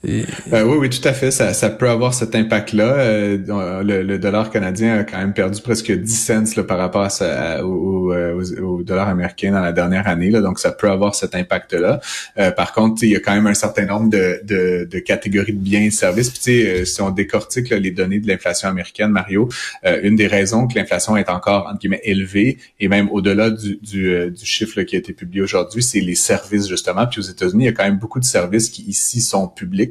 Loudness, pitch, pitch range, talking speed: -17 LUFS, 100 Hz, 95-110 Hz, 235 wpm